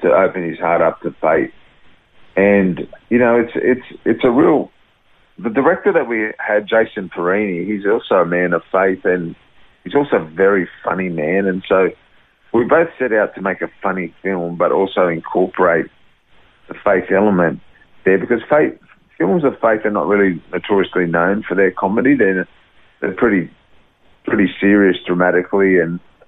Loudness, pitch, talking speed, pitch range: -16 LUFS, 95 Hz, 165 wpm, 90-105 Hz